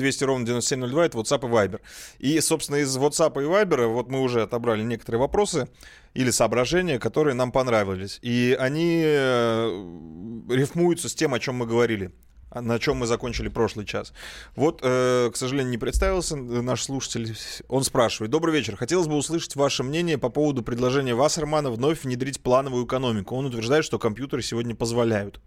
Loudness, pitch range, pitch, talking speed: -24 LUFS, 115-145 Hz, 125 Hz, 165 wpm